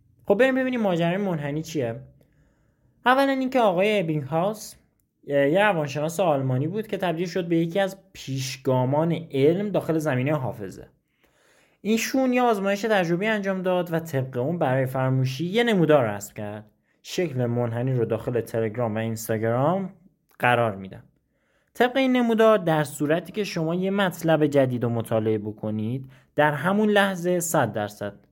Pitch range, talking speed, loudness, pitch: 125-195 Hz, 145 wpm, -24 LUFS, 155 Hz